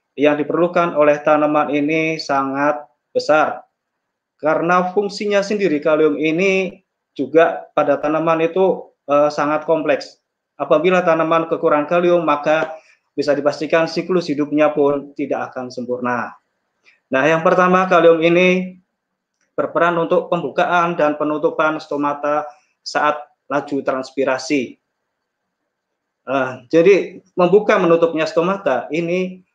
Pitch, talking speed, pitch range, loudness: 155 Hz, 105 wpm, 145-175 Hz, -17 LUFS